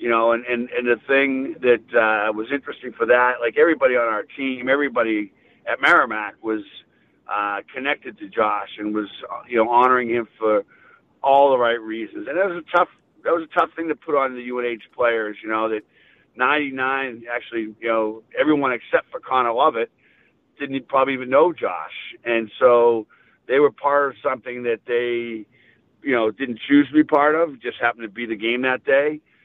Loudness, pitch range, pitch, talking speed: -21 LUFS, 115-135 Hz, 120 Hz, 195 wpm